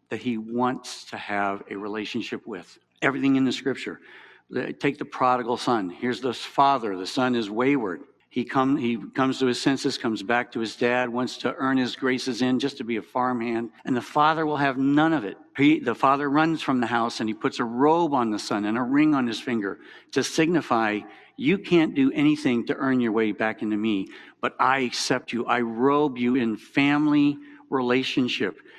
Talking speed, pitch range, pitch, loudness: 205 wpm, 115-140 Hz, 125 Hz, -24 LUFS